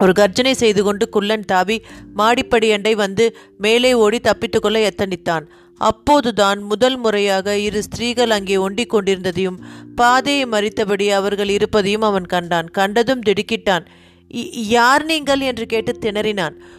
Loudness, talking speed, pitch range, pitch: -17 LUFS, 120 wpm, 195-230 Hz, 210 Hz